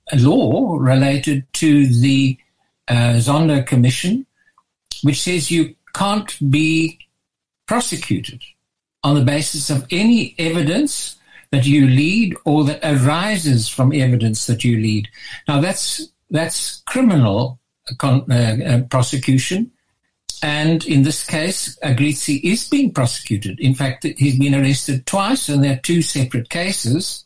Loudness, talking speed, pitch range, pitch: -17 LUFS, 130 wpm, 130-165 Hz, 145 Hz